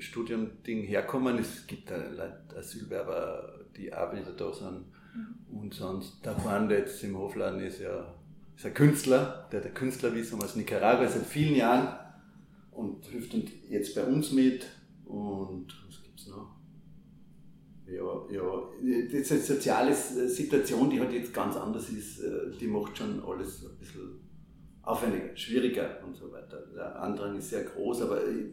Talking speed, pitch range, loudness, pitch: 145 wpm, 115-175 Hz, -31 LUFS, 130 Hz